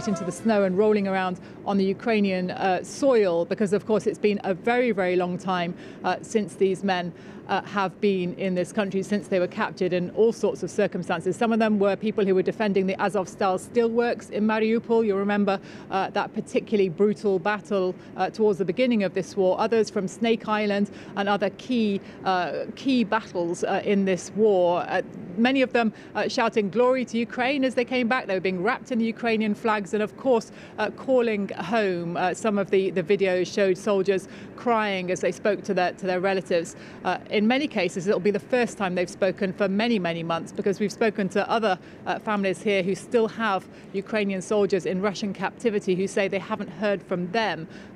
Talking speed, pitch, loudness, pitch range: 205 wpm, 200 Hz, -25 LUFS, 190-215 Hz